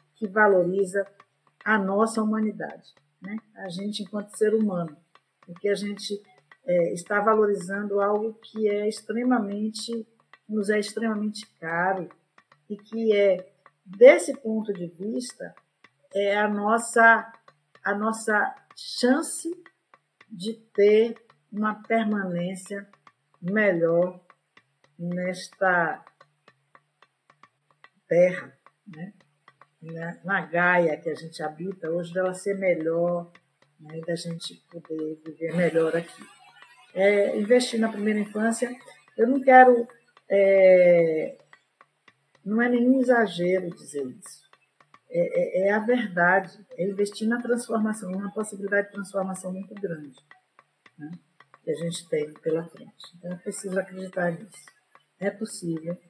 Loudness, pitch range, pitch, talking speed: -24 LUFS, 175-220 Hz, 200 Hz, 115 wpm